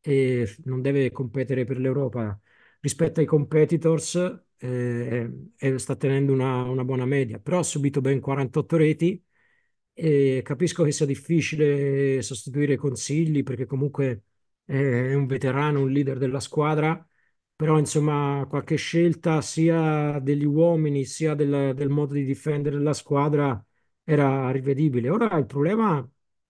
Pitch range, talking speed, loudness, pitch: 135-155 Hz, 140 wpm, -24 LUFS, 140 Hz